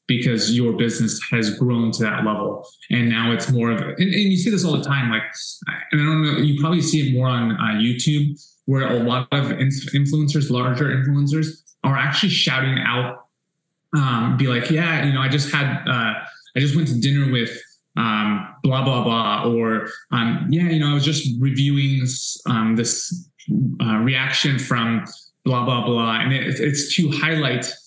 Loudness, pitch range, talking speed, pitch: -20 LUFS, 120-150 Hz, 190 wpm, 135 Hz